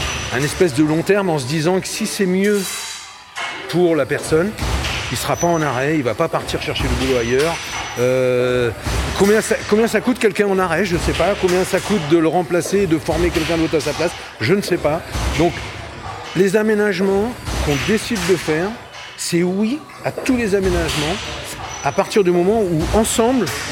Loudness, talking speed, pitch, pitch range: -18 LUFS, 195 wpm, 180 Hz, 160-205 Hz